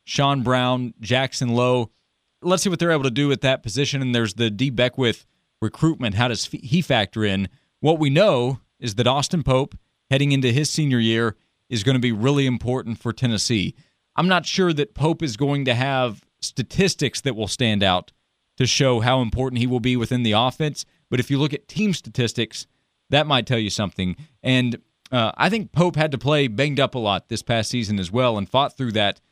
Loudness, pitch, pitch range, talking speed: -21 LUFS, 125 Hz, 115-140 Hz, 210 wpm